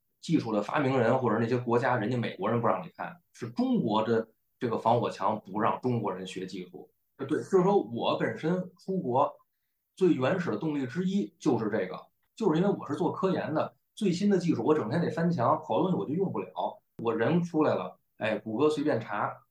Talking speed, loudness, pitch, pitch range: 310 characters per minute, -29 LUFS, 130 Hz, 115-170 Hz